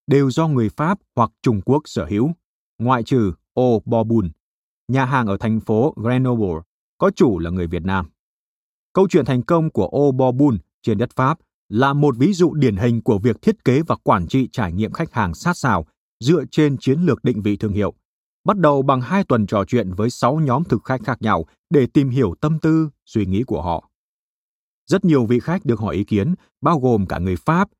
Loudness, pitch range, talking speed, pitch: -19 LUFS, 105-145 Hz, 210 wpm, 125 Hz